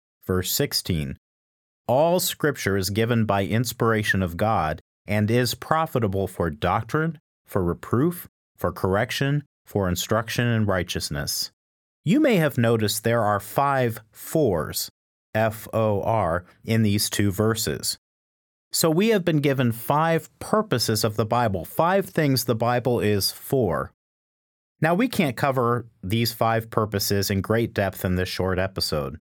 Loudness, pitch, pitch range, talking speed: -23 LUFS, 110 Hz, 95-125 Hz, 140 wpm